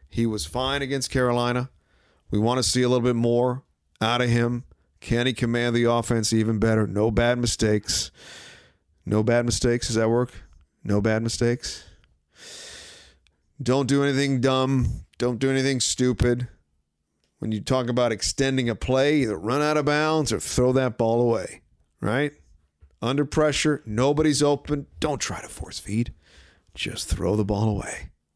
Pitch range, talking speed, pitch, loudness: 105-130 Hz, 160 wpm, 120 Hz, -24 LUFS